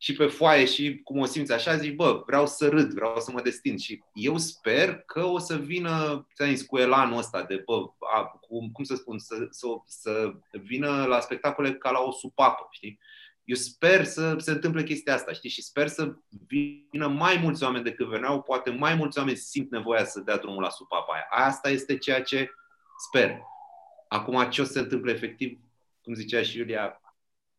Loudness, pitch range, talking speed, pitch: -27 LUFS, 125-155 Hz, 200 wpm, 140 Hz